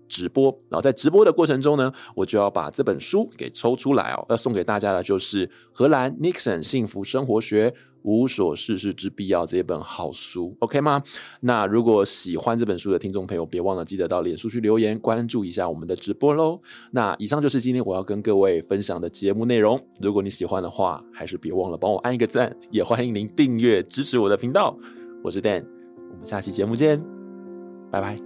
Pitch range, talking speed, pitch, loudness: 100-135 Hz, 330 characters per minute, 115 Hz, -23 LUFS